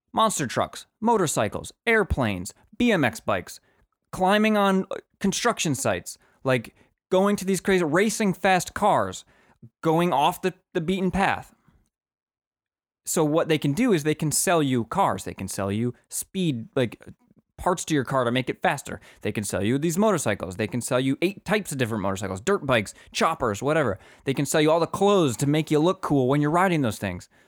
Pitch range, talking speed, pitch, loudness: 125-190 Hz, 185 wpm, 155 Hz, -24 LUFS